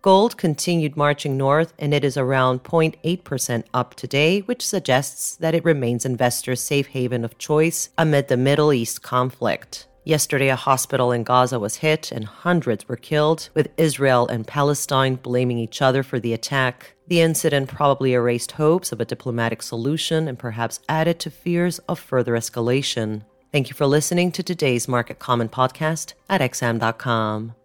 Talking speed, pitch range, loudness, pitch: 165 wpm, 125-155 Hz, -21 LUFS, 135 Hz